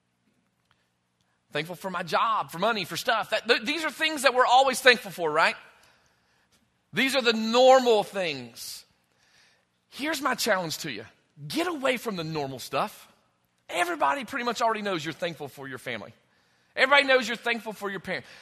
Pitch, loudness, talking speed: 190 Hz, -25 LUFS, 165 wpm